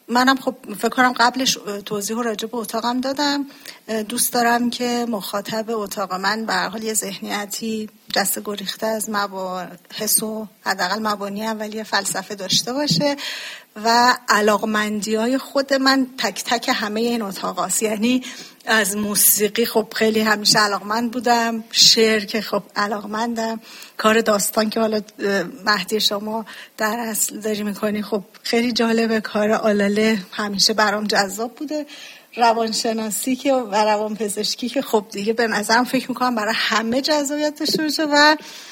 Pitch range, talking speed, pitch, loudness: 210-240 Hz, 140 wpm, 220 Hz, -19 LUFS